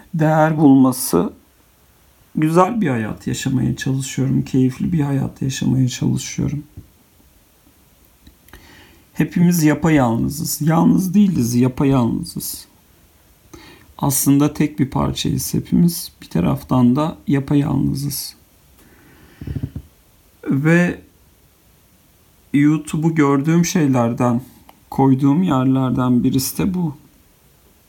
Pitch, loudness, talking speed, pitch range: 135 Hz, -17 LUFS, 80 wpm, 120-155 Hz